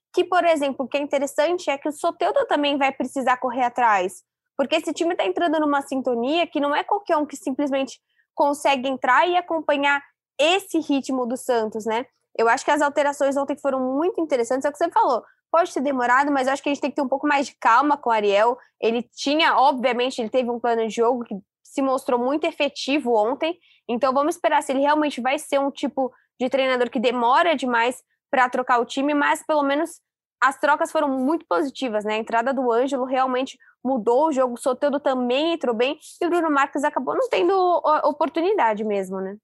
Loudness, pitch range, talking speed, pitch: -22 LUFS, 255-310 Hz, 210 wpm, 280 Hz